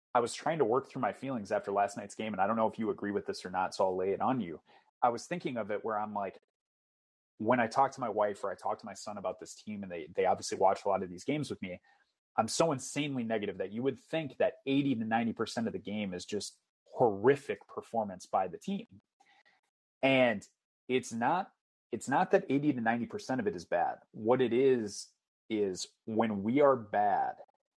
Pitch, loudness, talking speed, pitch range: 120 Hz, -33 LUFS, 235 wpm, 105-135 Hz